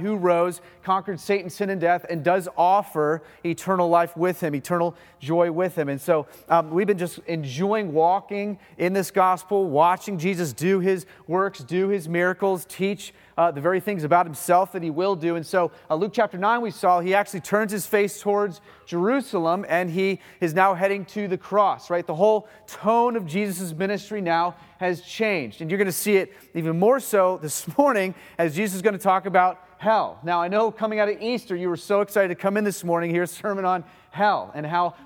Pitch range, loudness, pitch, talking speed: 170-200 Hz, -23 LUFS, 185 Hz, 210 wpm